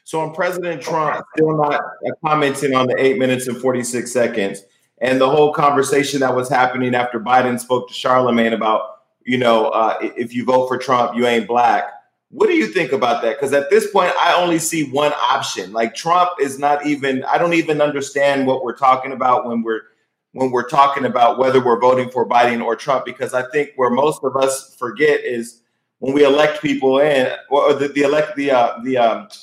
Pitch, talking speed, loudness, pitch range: 130 Hz, 210 wpm, -17 LUFS, 125-145 Hz